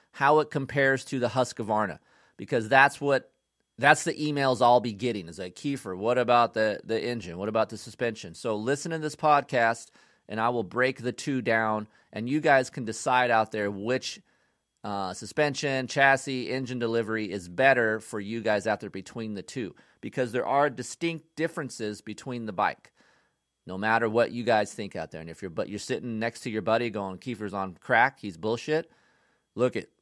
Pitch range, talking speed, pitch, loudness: 110-135 Hz, 190 wpm, 120 Hz, -27 LUFS